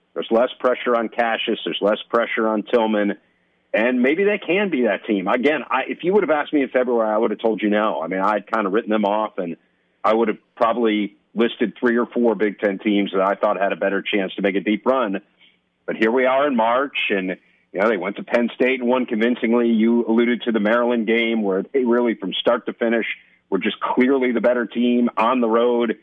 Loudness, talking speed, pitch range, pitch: -20 LUFS, 240 wpm, 105-120 Hz, 115 Hz